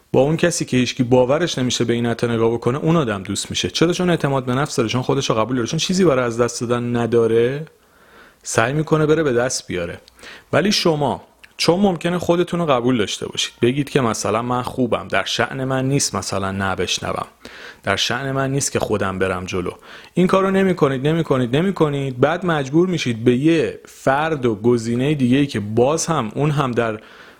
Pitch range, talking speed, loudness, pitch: 120-160 Hz, 195 wpm, -19 LUFS, 130 Hz